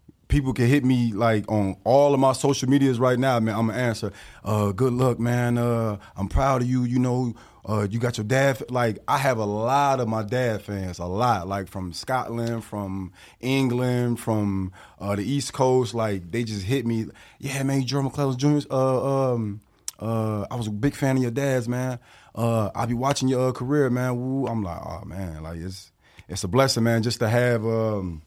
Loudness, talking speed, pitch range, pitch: -24 LUFS, 215 wpm, 105-130 Hz, 120 Hz